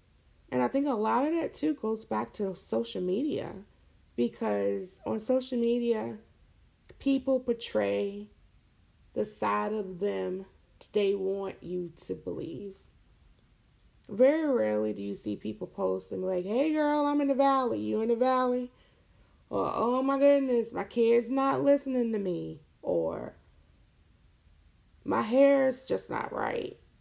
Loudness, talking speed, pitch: -30 LUFS, 140 wpm, 195 Hz